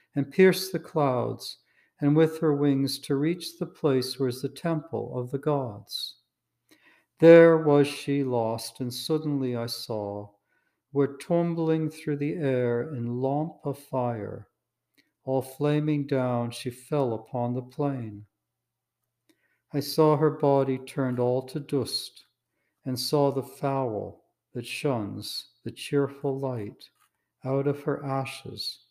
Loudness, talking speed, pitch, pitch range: -26 LUFS, 135 wpm, 140 Hz, 125-150 Hz